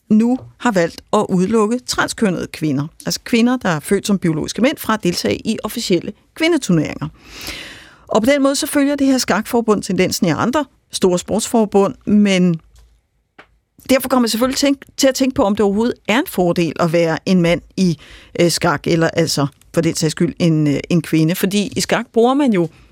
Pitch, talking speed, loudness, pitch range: 200 Hz, 185 wpm, -16 LUFS, 170-240 Hz